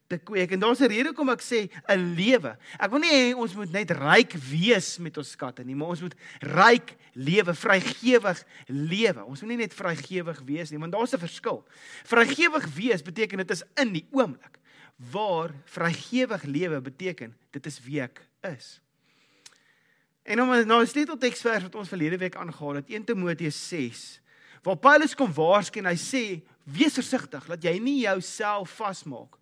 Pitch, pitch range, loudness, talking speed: 185 Hz, 155-235 Hz, -25 LUFS, 180 wpm